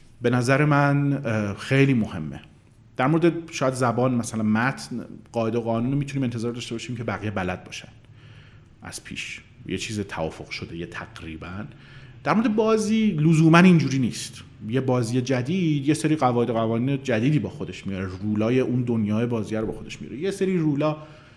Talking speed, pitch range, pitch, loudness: 160 wpm, 110-140 Hz, 120 Hz, -23 LUFS